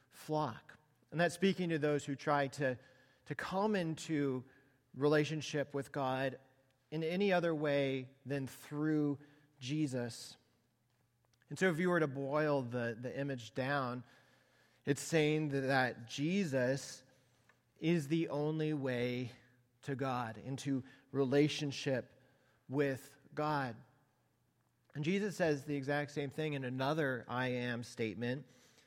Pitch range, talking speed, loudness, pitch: 125-150 Hz, 125 wpm, -37 LUFS, 135 Hz